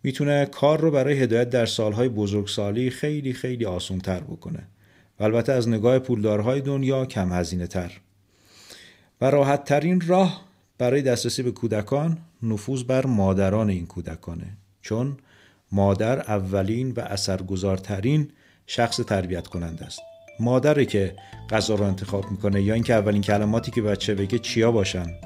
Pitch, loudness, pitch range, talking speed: 110 Hz, -23 LUFS, 100-130 Hz, 140 wpm